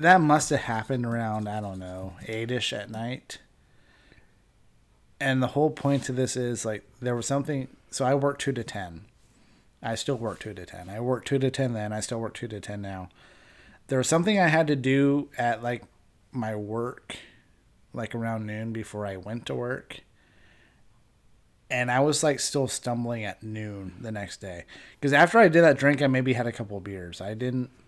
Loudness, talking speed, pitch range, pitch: -27 LUFS, 200 wpm, 105-135 Hz, 120 Hz